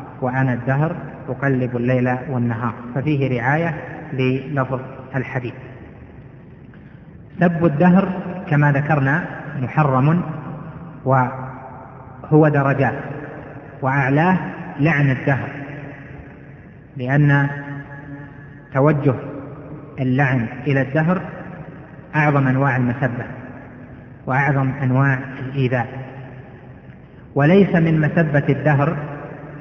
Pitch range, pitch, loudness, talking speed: 130-150 Hz, 140 Hz, -19 LUFS, 70 wpm